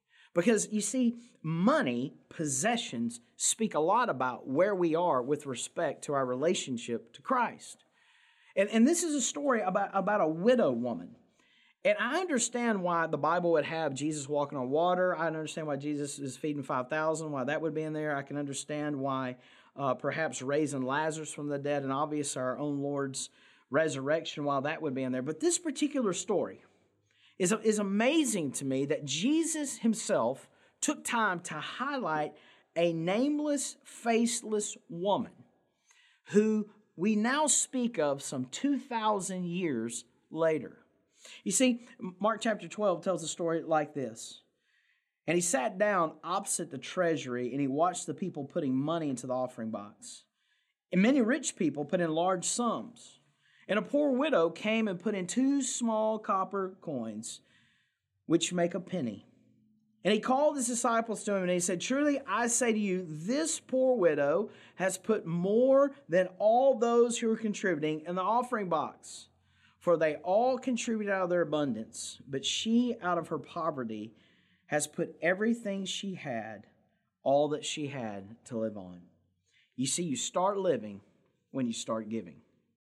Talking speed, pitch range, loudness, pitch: 160 wpm, 145-230 Hz, -31 LUFS, 180 Hz